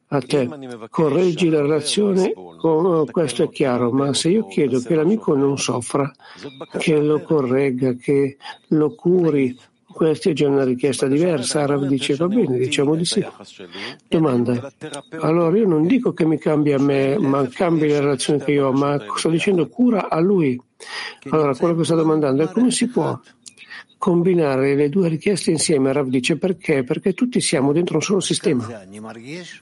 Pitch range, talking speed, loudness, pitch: 140-175 Hz, 170 wpm, -19 LUFS, 150 Hz